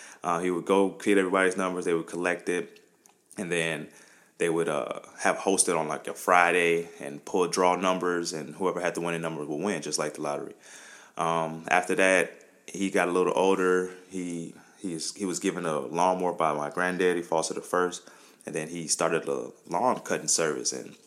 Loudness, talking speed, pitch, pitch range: -27 LUFS, 190 wpm, 90 Hz, 85-90 Hz